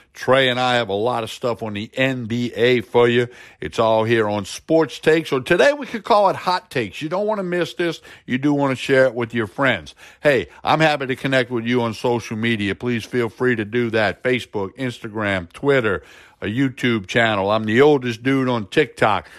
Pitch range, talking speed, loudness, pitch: 115-140 Hz, 215 wpm, -19 LUFS, 125 Hz